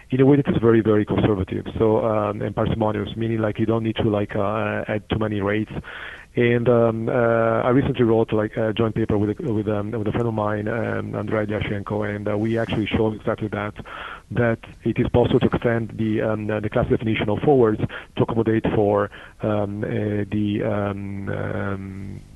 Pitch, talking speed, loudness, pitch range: 110 Hz, 195 wpm, -22 LUFS, 105-115 Hz